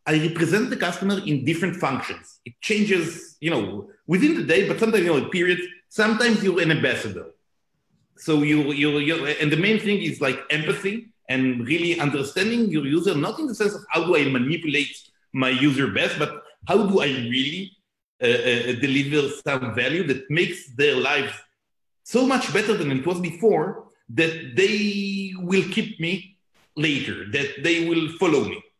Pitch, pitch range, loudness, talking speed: 170 Hz, 145-195 Hz, -22 LUFS, 175 wpm